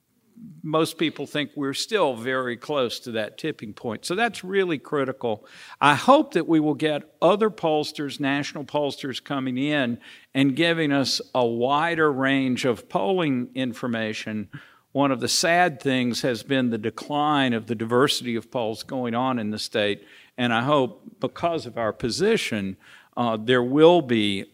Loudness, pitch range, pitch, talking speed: -23 LUFS, 120-155 Hz, 135 Hz, 160 wpm